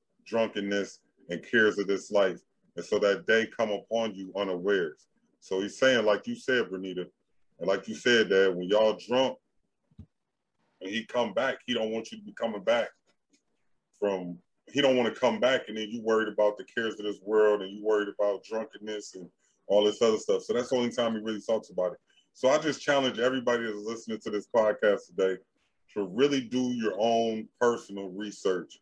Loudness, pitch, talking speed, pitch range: -28 LUFS, 110 Hz, 200 wpm, 100-120 Hz